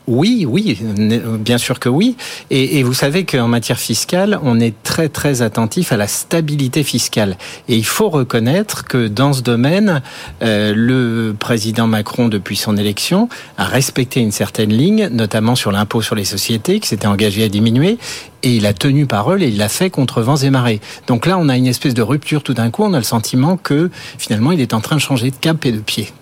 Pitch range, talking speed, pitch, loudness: 115-145 Hz, 215 wpm, 125 Hz, -15 LUFS